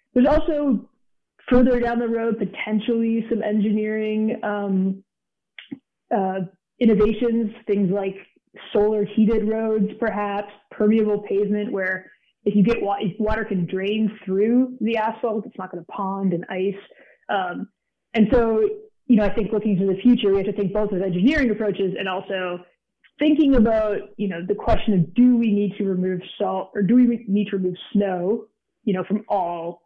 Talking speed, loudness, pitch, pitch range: 170 wpm, -22 LUFS, 210 Hz, 195-230 Hz